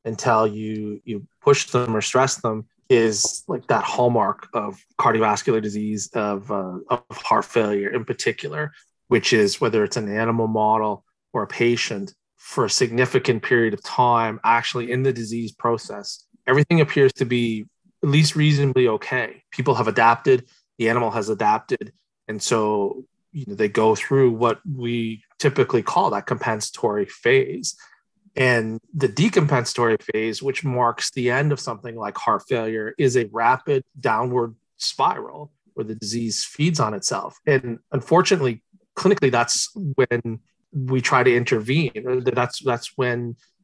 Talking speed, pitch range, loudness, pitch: 150 wpm, 110-140 Hz, -21 LUFS, 120 Hz